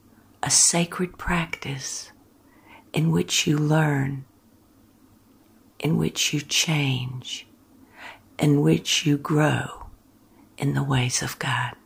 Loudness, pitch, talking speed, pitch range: -23 LUFS, 145 Hz, 100 wpm, 135-160 Hz